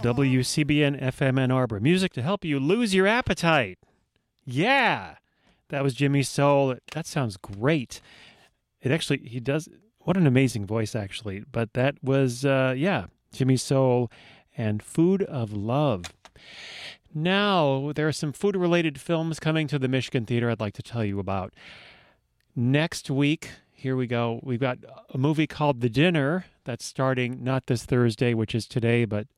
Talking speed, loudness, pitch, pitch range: 160 wpm, -25 LUFS, 135 Hz, 120-155 Hz